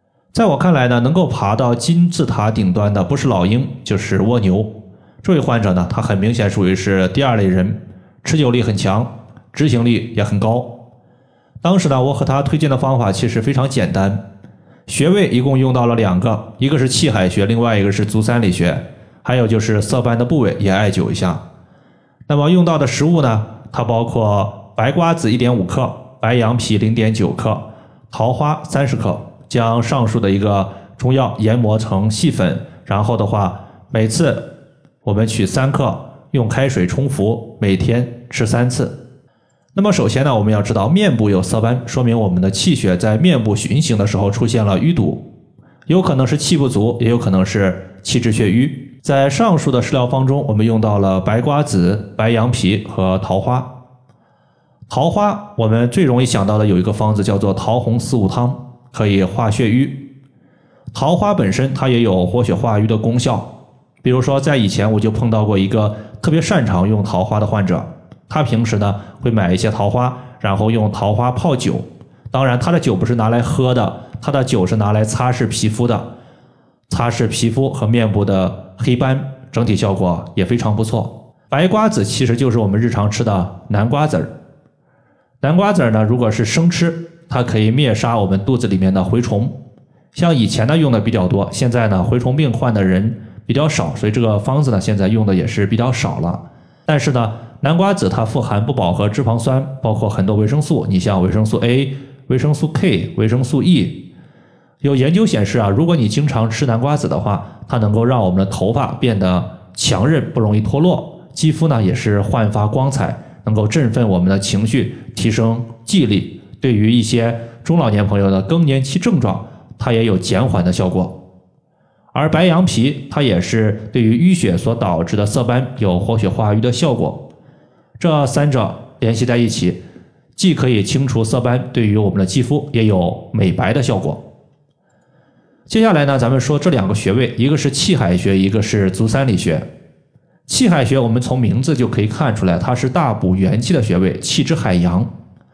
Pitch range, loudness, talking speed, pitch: 105-135 Hz, -15 LUFS, 275 characters per minute, 120 Hz